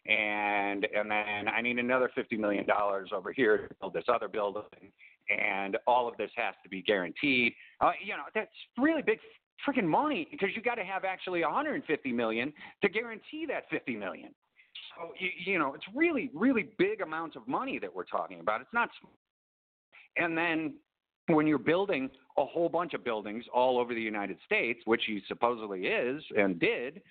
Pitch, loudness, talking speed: 145 Hz, -31 LUFS, 185 wpm